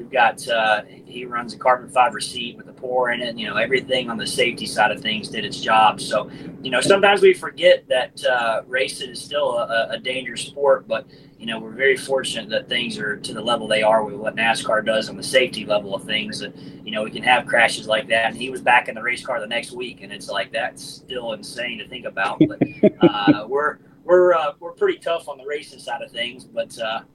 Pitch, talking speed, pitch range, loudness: 130 Hz, 245 wpm, 115-165 Hz, -20 LUFS